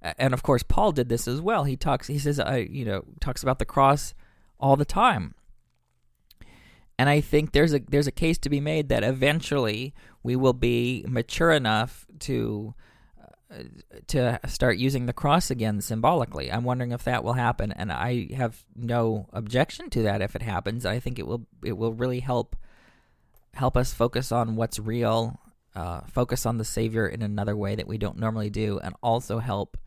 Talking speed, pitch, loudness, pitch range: 190 wpm, 120 Hz, -26 LUFS, 110-130 Hz